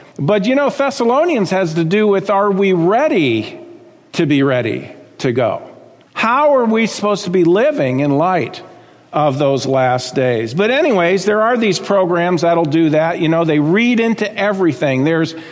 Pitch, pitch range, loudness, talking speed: 190 Hz, 160-230 Hz, -14 LUFS, 175 wpm